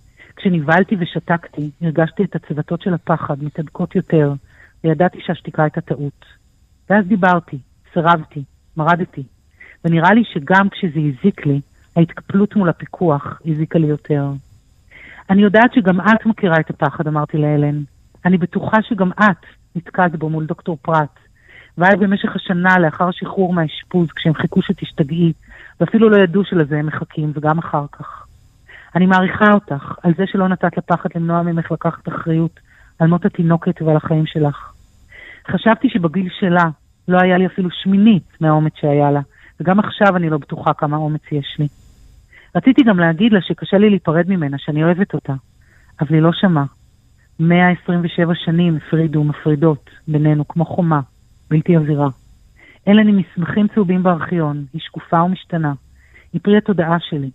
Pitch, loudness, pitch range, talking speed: 165 Hz, -16 LUFS, 150-185 Hz, 145 wpm